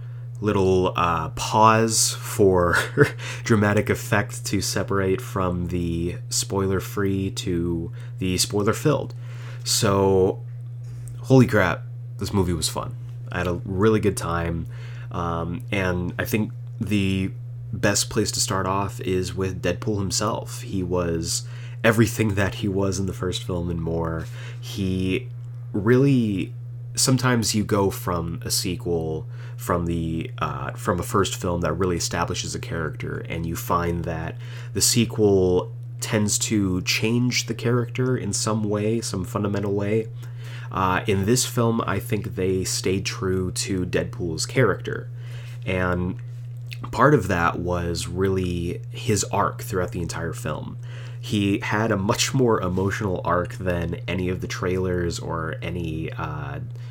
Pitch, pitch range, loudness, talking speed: 110 Hz, 95-120 Hz, -23 LUFS, 140 wpm